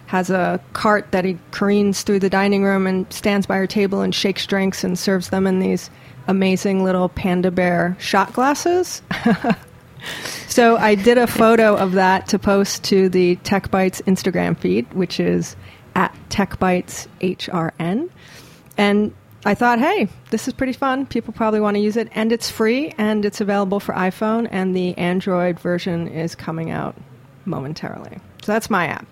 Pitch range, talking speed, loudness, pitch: 185-215 Hz, 165 wpm, -19 LUFS, 195 Hz